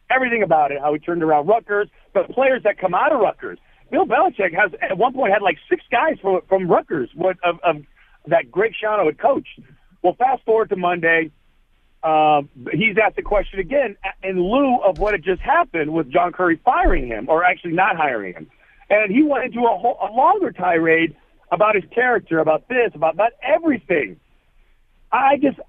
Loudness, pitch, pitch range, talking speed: -19 LUFS, 195 Hz, 165-245 Hz, 195 wpm